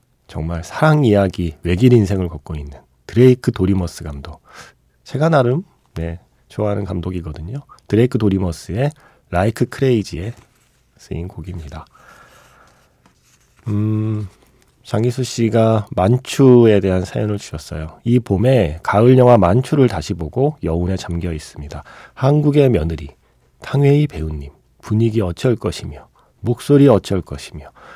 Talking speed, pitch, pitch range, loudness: 295 characters per minute, 105 Hz, 85-125 Hz, -16 LUFS